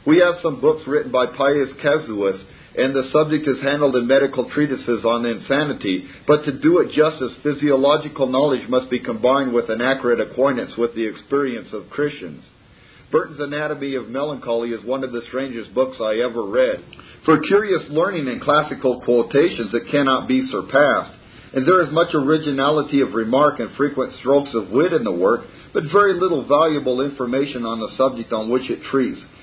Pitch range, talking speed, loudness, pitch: 120-150 Hz, 175 wpm, -19 LUFS, 135 Hz